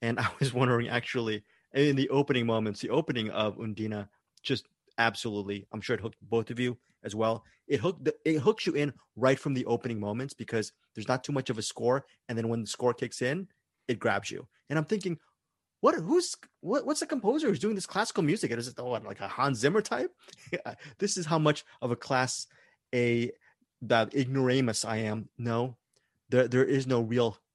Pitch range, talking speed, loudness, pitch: 115-145 Hz, 205 wpm, -30 LUFS, 125 Hz